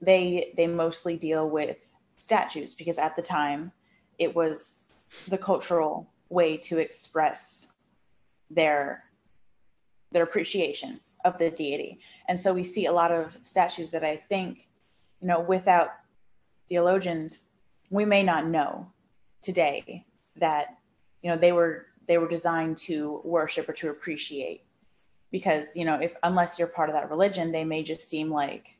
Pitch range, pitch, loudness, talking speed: 155-175 Hz, 170 Hz, -27 LUFS, 150 wpm